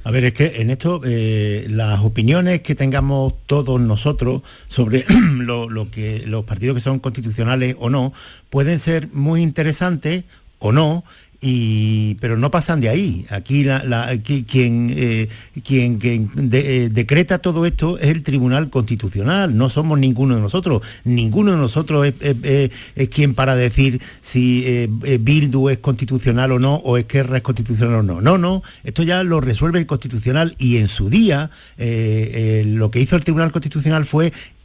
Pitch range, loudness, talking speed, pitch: 115-150 Hz, -17 LUFS, 175 wpm, 130 Hz